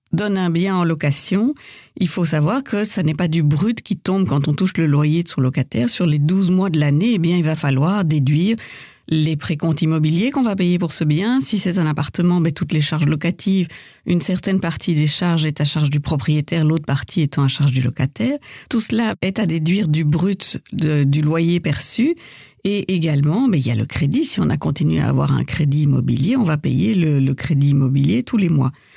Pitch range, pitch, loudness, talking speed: 150-190 Hz, 165 Hz, -18 LUFS, 225 wpm